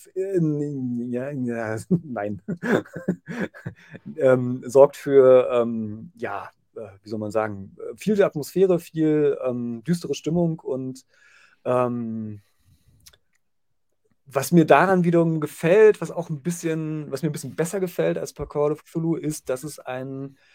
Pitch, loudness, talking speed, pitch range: 140 Hz, -23 LUFS, 135 wpm, 120-165 Hz